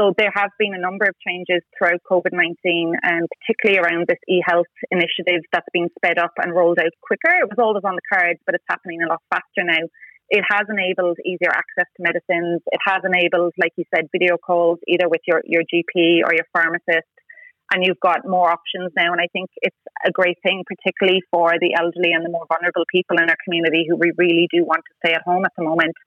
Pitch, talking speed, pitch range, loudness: 175 Hz, 230 wpm, 170-185 Hz, -18 LUFS